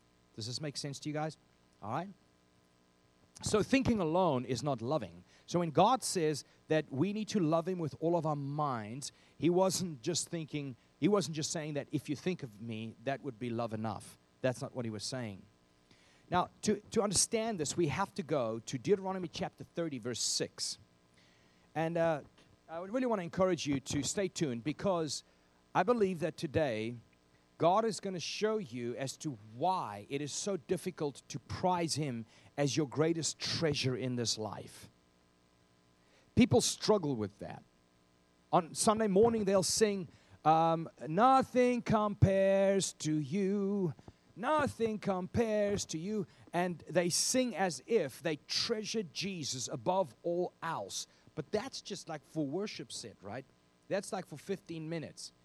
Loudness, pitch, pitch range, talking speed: -34 LUFS, 155 Hz, 115-190 Hz, 165 wpm